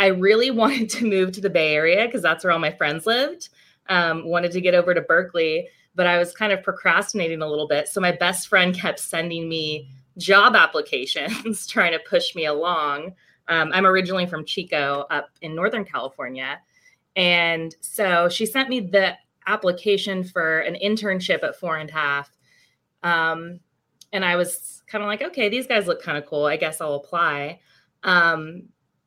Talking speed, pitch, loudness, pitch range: 185 wpm, 180 Hz, -21 LUFS, 160-205 Hz